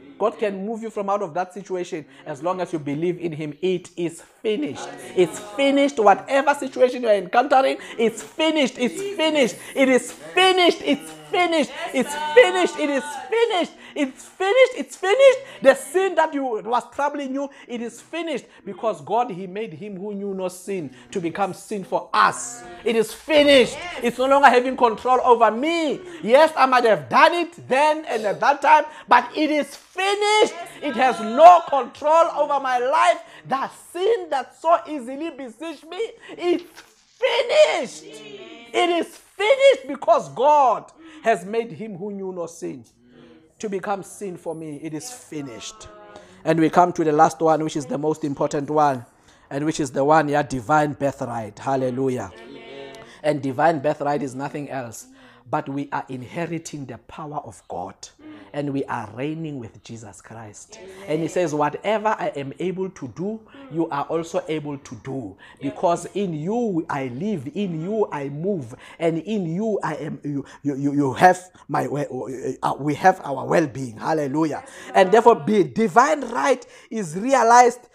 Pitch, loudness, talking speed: 210 Hz, -21 LUFS, 175 wpm